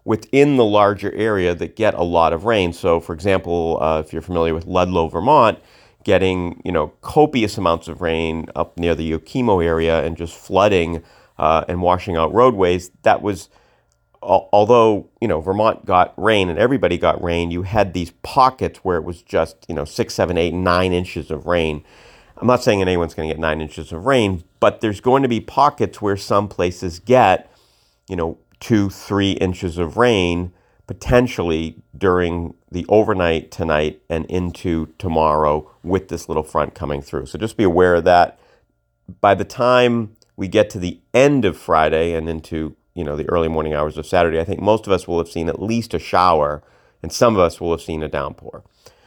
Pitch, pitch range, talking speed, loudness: 90 Hz, 80-100 Hz, 195 wpm, -18 LUFS